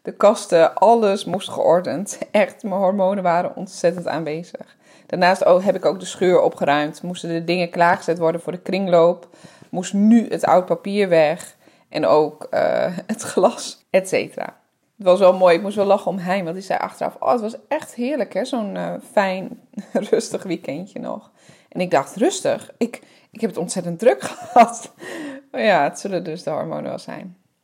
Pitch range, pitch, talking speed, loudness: 175-230 Hz, 190 Hz, 185 wpm, -19 LUFS